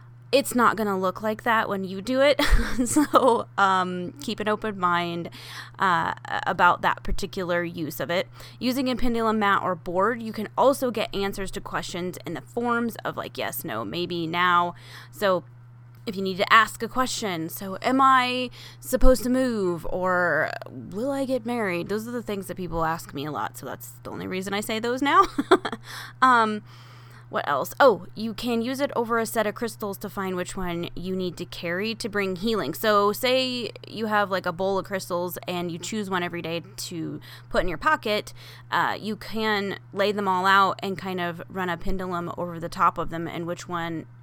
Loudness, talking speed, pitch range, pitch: -25 LUFS, 200 wpm, 170-225 Hz, 190 Hz